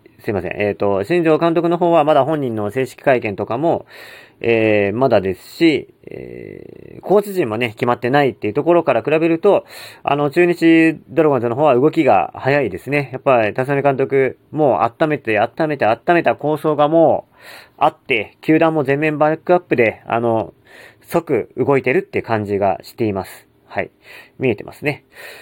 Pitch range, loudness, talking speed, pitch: 125-170 Hz, -17 LUFS, 350 characters per minute, 150 Hz